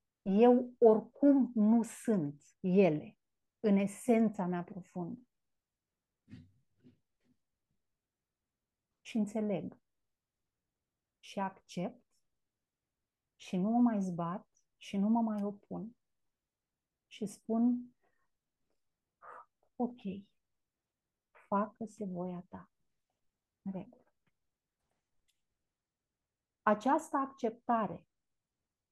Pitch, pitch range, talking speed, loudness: 215 Hz, 195-240 Hz, 70 wpm, -33 LUFS